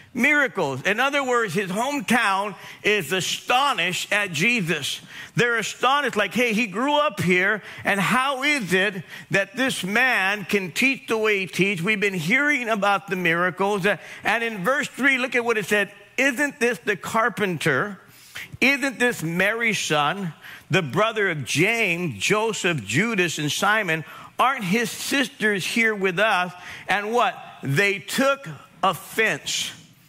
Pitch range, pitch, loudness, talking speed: 180-235 Hz, 205 Hz, -22 LUFS, 150 wpm